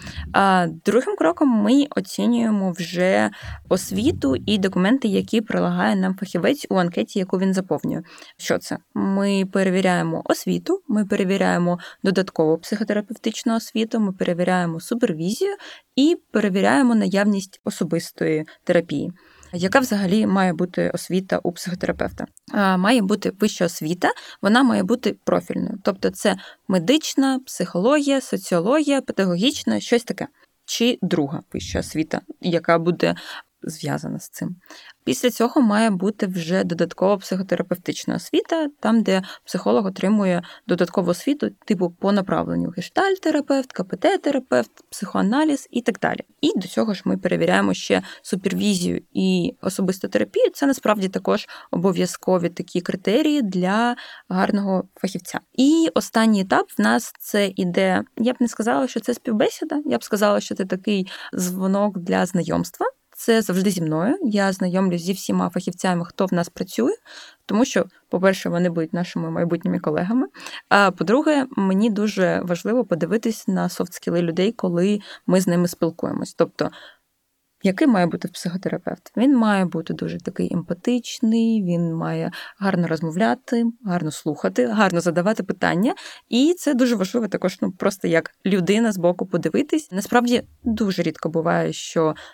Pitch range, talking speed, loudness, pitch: 180-240 Hz, 135 wpm, -21 LUFS, 195 Hz